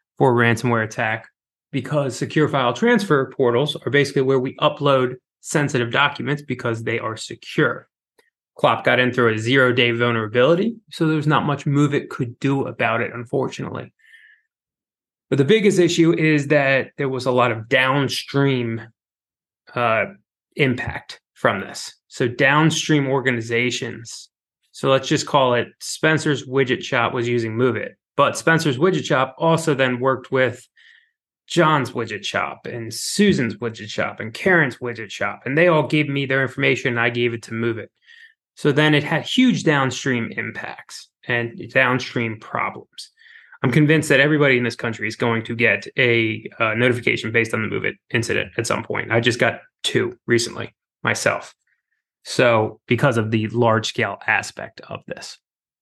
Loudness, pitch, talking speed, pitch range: -19 LUFS, 130 Hz, 160 wpm, 120-150 Hz